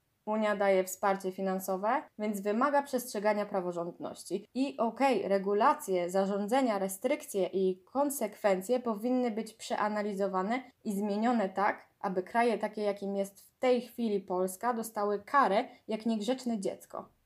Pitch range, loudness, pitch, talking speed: 195-240 Hz, -32 LUFS, 210 Hz, 120 wpm